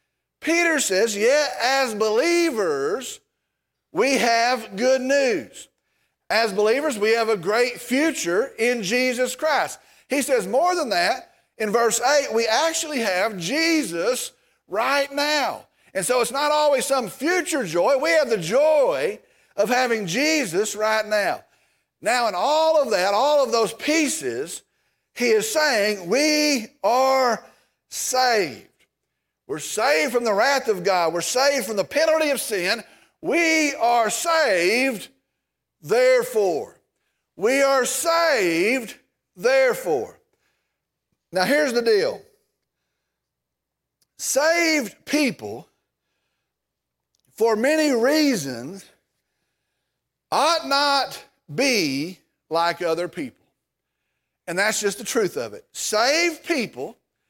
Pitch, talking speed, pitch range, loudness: 275 Hz, 115 wpm, 225-320 Hz, -21 LUFS